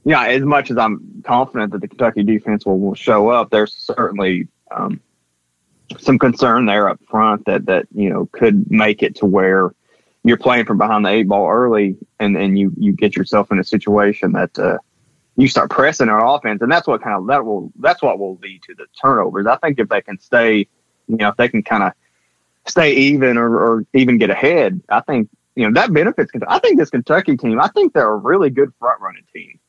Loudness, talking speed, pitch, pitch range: -15 LUFS, 220 wpm, 105 Hz, 100-120 Hz